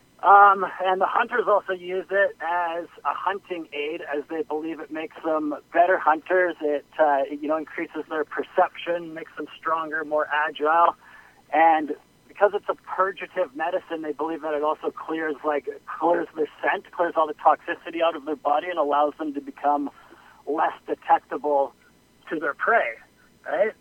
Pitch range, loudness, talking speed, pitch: 150-180 Hz, -24 LUFS, 170 wpm, 160 Hz